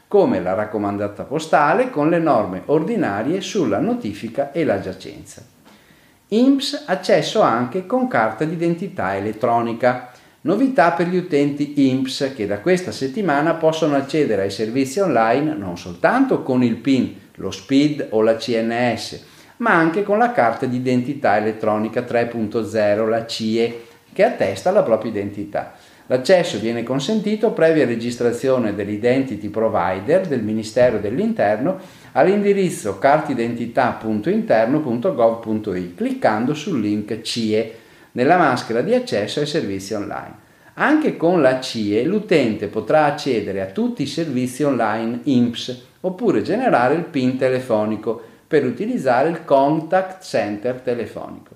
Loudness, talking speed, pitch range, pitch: -19 LUFS, 125 wpm, 110-155 Hz, 125 Hz